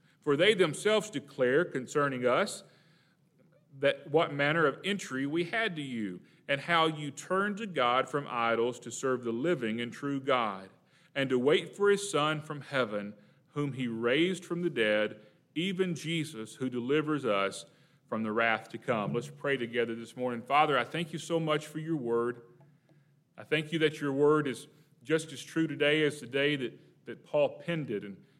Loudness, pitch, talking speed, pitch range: -31 LUFS, 145 Hz, 185 wpm, 120-160 Hz